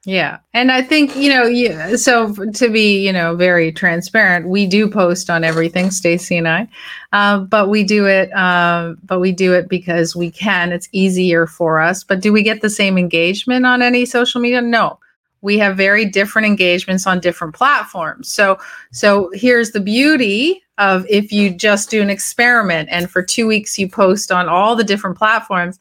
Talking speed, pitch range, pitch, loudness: 195 wpm, 180-220 Hz, 200 Hz, -14 LUFS